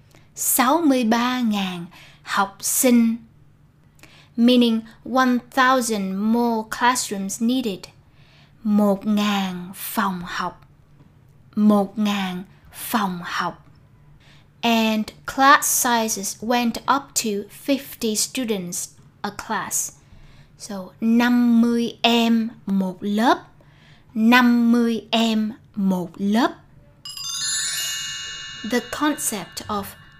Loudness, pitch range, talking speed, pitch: -21 LUFS, 175-235 Hz, 70 wpm, 210 Hz